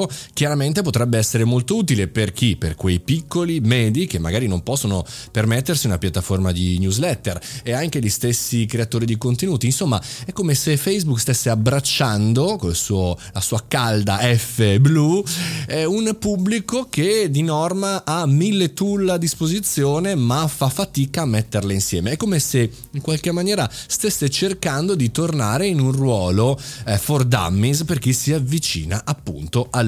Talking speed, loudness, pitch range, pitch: 155 wpm, -19 LUFS, 110-160 Hz, 130 Hz